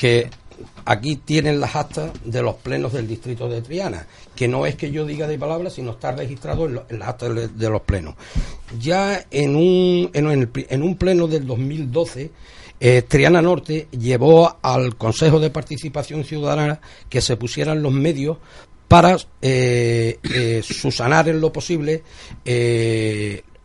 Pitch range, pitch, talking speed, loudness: 120-155 Hz, 140 Hz, 150 wpm, -19 LUFS